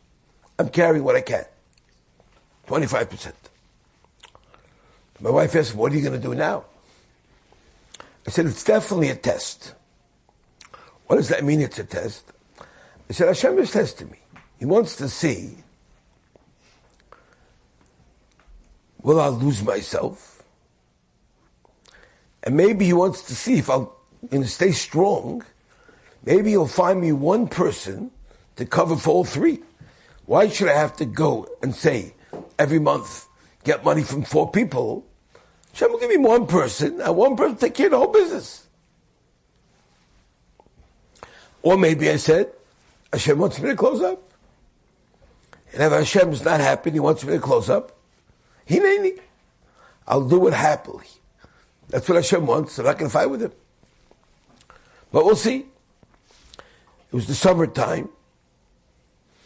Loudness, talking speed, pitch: -20 LUFS, 145 wpm, 165 Hz